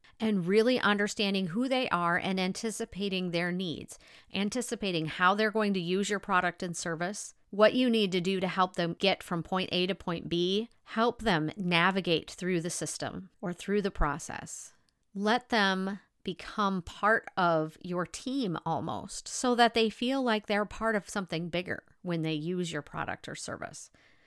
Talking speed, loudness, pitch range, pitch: 175 wpm, -30 LUFS, 175-215 Hz, 190 Hz